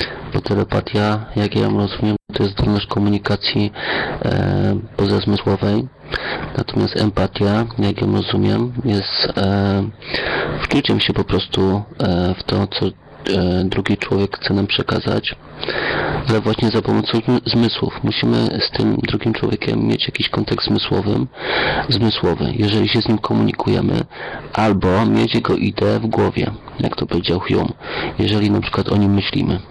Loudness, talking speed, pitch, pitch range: -18 LUFS, 140 wpm, 105 Hz, 100-115 Hz